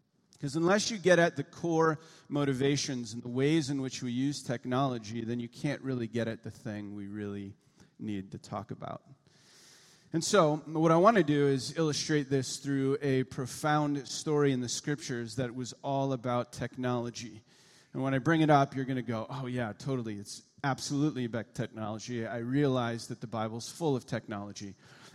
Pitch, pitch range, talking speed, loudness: 135 Hz, 120-150 Hz, 185 wpm, -31 LUFS